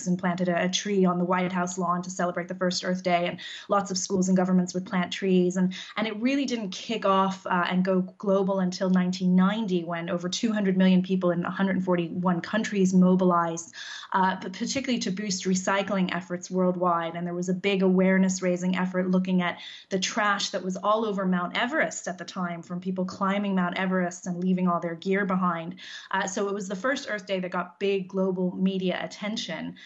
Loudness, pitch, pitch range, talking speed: -26 LUFS, 185 Hz, 180-195 Hz, 200 wpm